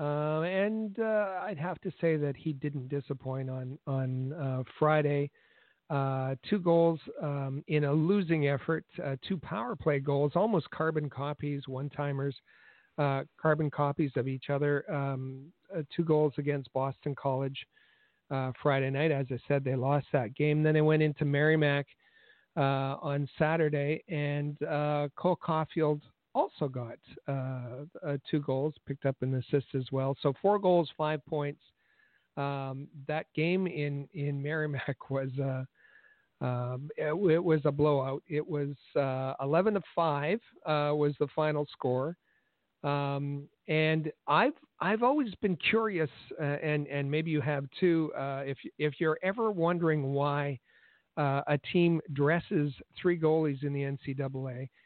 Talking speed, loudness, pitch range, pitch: 155 wpm, -31 LUFS, 140-160 Hz, 145 Hz